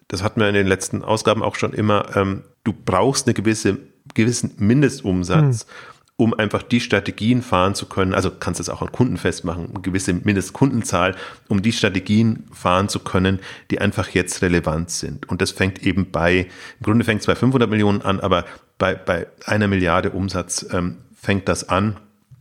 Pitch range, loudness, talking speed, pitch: 95-110 Hz, -20 LUFS, 180 wpm, 100 Hz